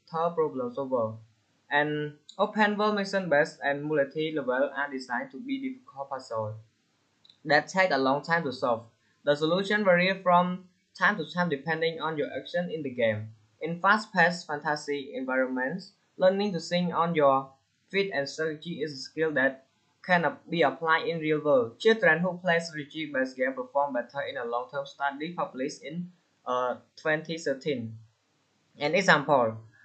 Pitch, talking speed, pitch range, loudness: 150 Hz, 150 wpm, 135-175 Hz, -28 LUFS